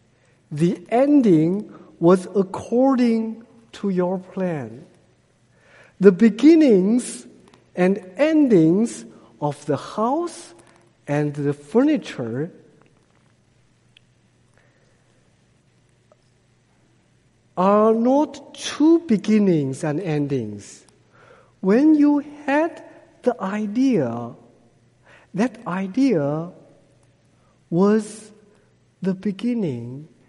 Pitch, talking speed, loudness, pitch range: 190 Hz, 65 wpm, -20 LUFS, 145-240 Hz